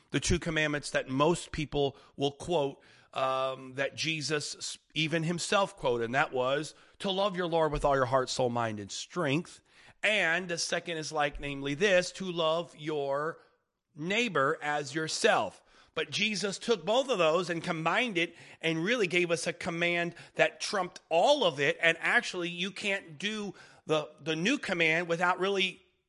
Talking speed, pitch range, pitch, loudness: 170 wpm, 145-180 Hz, 165 Hz, -30 LUFS